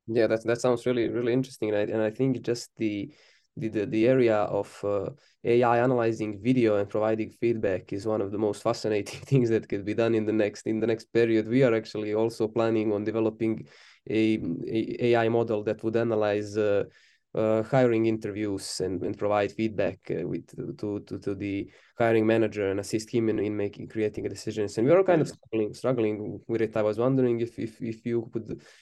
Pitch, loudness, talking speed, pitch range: 110 Hz, -27 LUFS, 205 wpm, 105-115 Hz